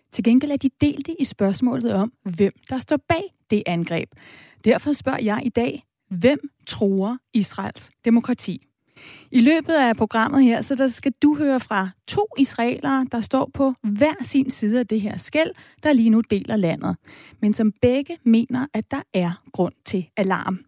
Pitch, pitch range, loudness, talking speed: 240 Hz, 210-270 Hz, -21 LUFS, 175 wpm